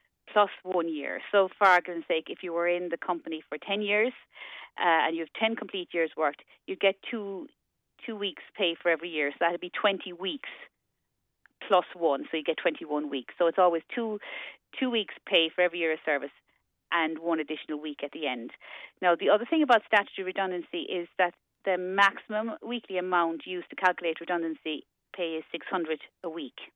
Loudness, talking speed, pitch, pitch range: -29 LUFS, 200 wpm, 180 Hz, 165-200 Hz